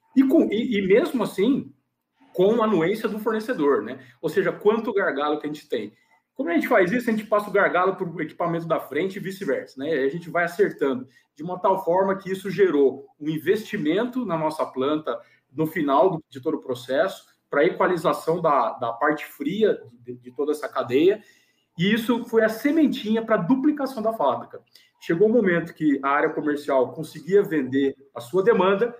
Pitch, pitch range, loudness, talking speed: 180 Hz, 150-220 Hz, -23 LUFS, 195 wpm